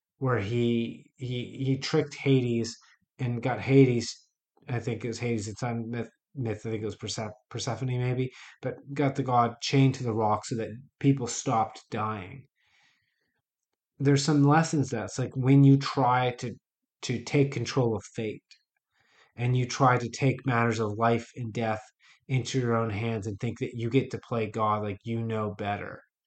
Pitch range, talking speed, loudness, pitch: 115-130 Hz, 180 wpm, -28 LUFS, 120 Hz